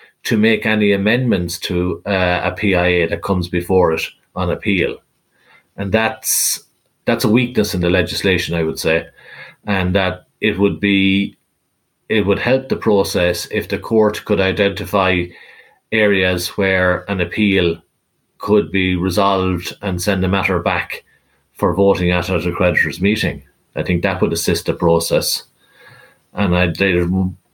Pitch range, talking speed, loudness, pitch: 90-100 Hz, 145 wpm, -17 LUFS, 95 Hz